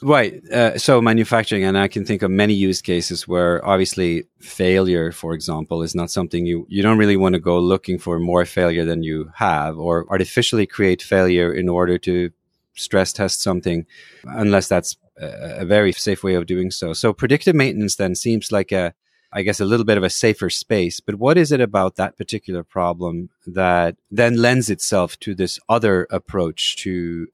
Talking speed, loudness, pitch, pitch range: 190 wpm, -19 LUFS, 95 Hz, 90-105 Hz